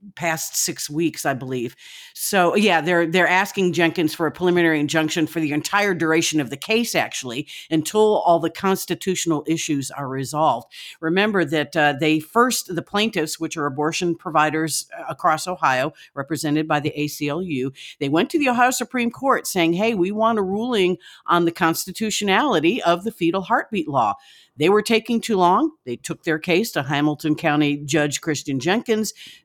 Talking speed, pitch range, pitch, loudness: 170 wpm, 150-200 Hz, 165 Hz, -21 LUFS